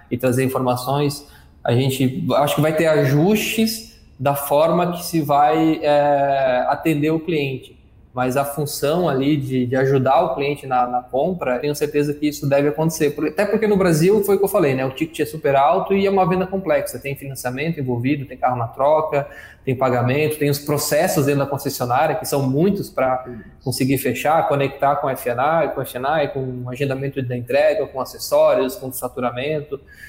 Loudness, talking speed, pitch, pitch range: -19 LUFS, 185 wpm, 145 Hz, 130-155 Hz